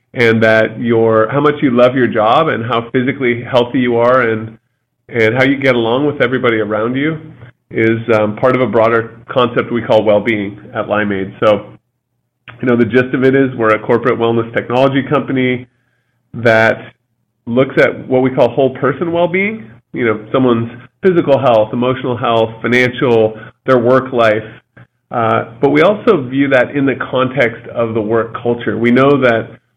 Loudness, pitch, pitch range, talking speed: -13 LUFS, 120 Hz, 115-130 Hz, 180 wpm